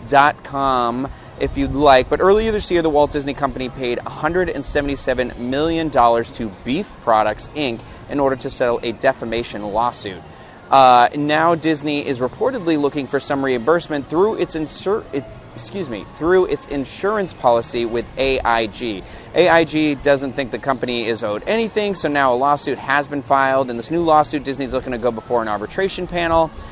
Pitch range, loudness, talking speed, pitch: 120-155 Hz, -18 LUFS, 170 wpm, 140 Hz